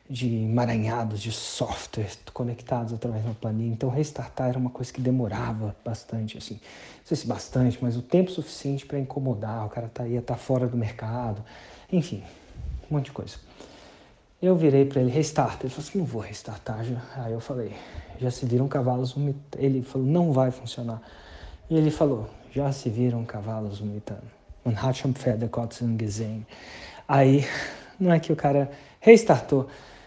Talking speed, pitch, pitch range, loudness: 160 wpm, 125 Hz, 115-140 Hz, -26 LUFS